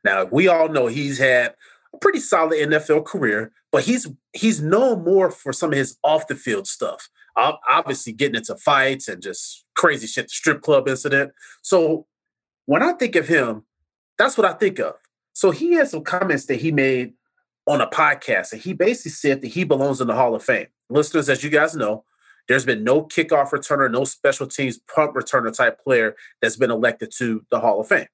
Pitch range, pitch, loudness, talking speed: 135-185 Hz, 155 Hz, -20 LUFS, 205 wpm